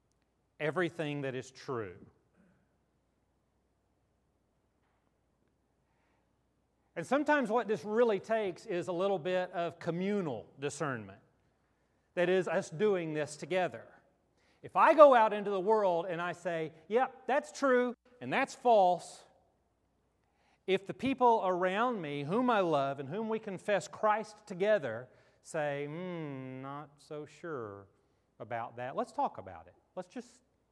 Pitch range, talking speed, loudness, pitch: 145-220 Hz, 130 wpm, -32 LUFS, 180 Hz